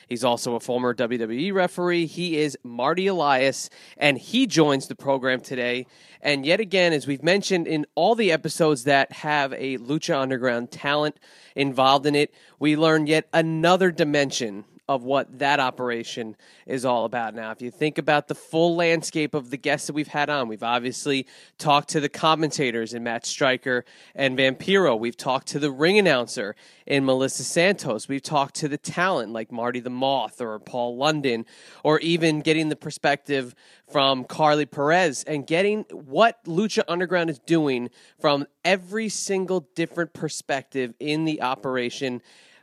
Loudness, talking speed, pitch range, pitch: -23 LUFS, 165 wpm, 130-165 Hz, 145 Hz